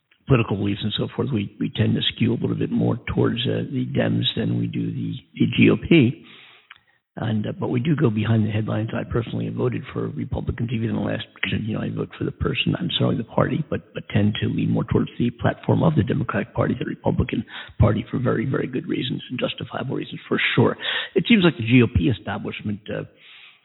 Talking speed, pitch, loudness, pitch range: 225 wpm, 110 Hz, -23 LUFS, 105-125 Hz